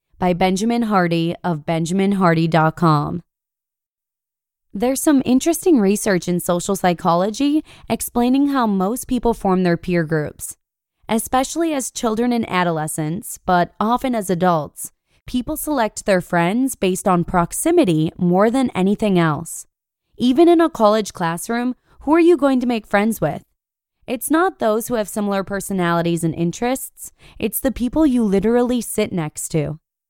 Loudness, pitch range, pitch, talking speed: -18 LUFS, 175-245 Hz, 205 Hz, 140 wpm